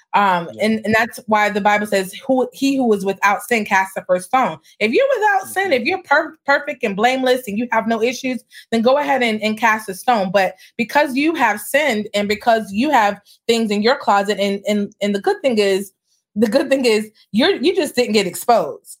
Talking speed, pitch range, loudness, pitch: 225 wpm, 205-270 Hz, -17 LUFS, 230 Hz